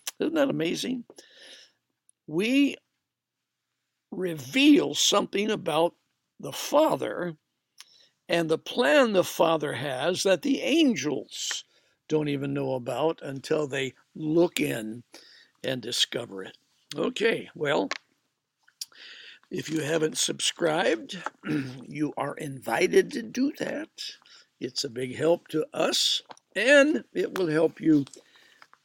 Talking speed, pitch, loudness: 110 wpm, 165 Hz, -26 LUFS